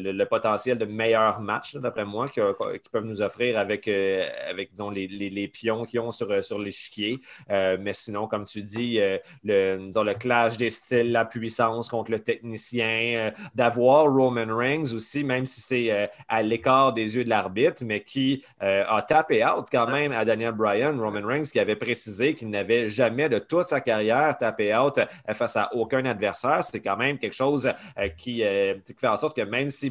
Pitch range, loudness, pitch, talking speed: 105-130 Hz, -25 LUFS, 115 Hz, 205 wpm